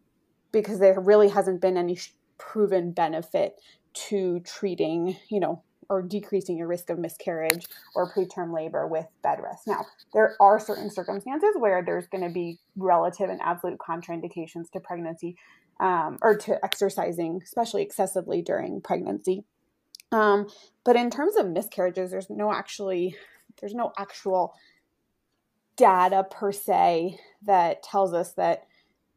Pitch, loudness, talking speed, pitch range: 190 Hz, -26 LUFS, 140 wpm, 175-205 Hz